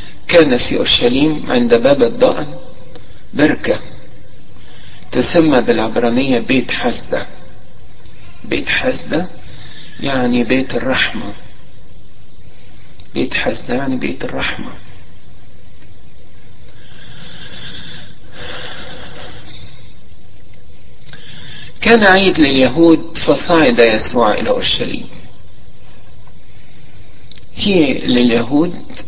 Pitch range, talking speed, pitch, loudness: 100-155 Hz, 60 wpm, 120 Hz, -13 LUFS